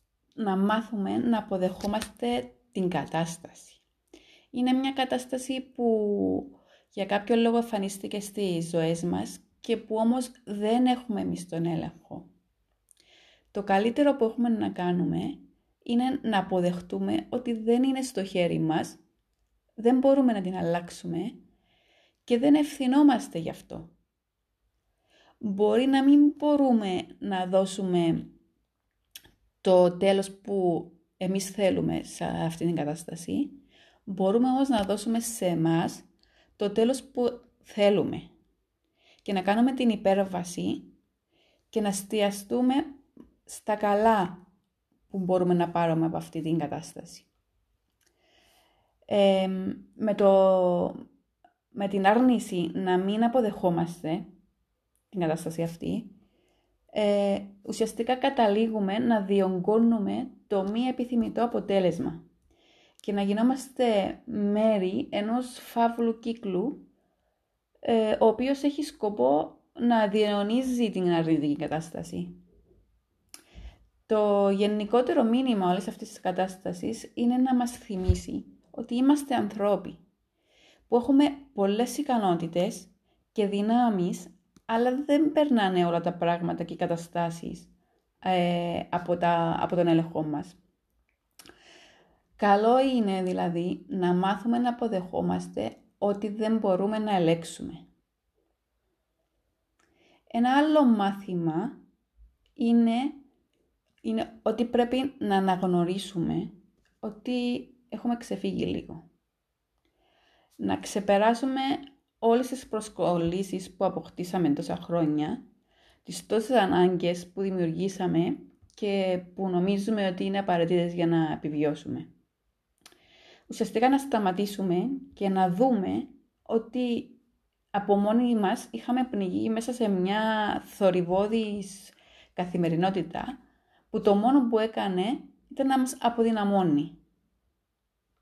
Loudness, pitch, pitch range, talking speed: -27 LUFS, 205 Hz, 180-245 Hz, 105 wpm